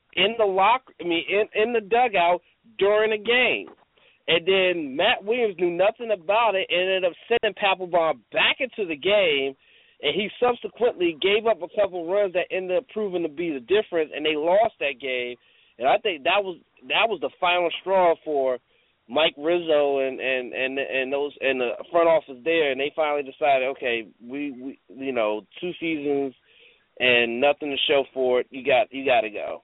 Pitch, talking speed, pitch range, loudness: 175 Hz, 195 wpm, 140-210 Hz, -23 LUFS